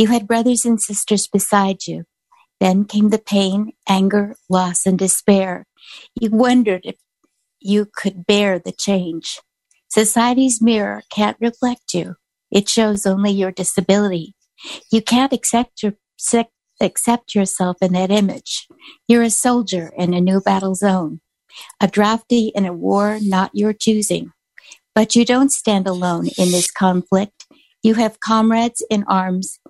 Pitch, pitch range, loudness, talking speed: 205 Hz, 190-230 Hz, -17 LUFS, 140 wpm